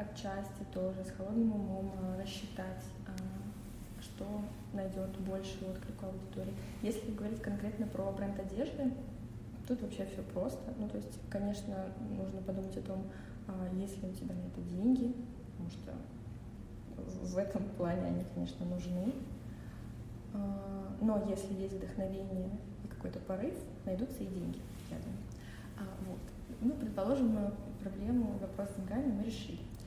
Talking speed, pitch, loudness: 130 wpm, 190 Hz, -40 LUFS